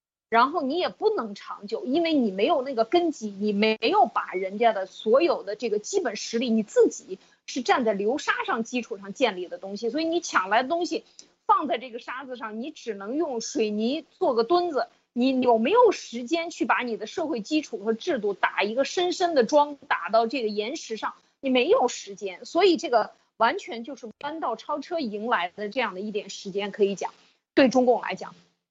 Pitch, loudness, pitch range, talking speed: 245 Hz, -25 LUFS, 215-315 Hz, 295 characters per minute